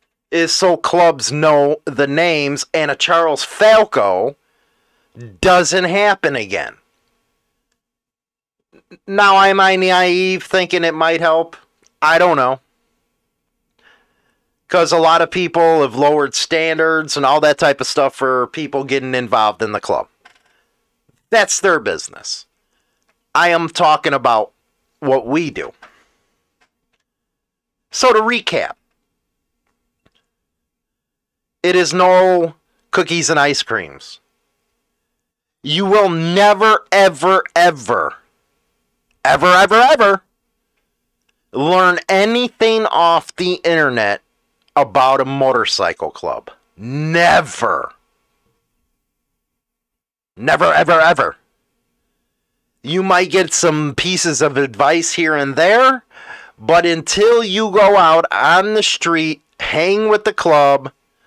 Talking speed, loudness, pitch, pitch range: 105 wpm, -14 LUFS, 170 Hz, 150-190 Hz